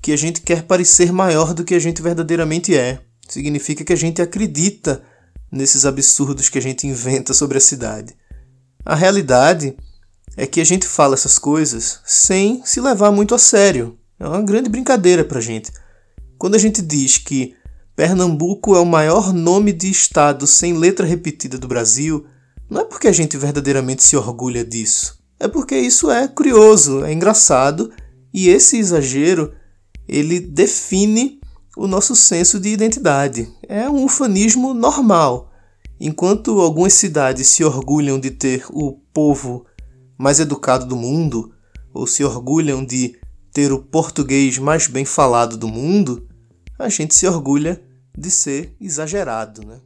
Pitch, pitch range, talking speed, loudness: 145 Hz, 130-185 Hz, 155 wpm, -14 LUFS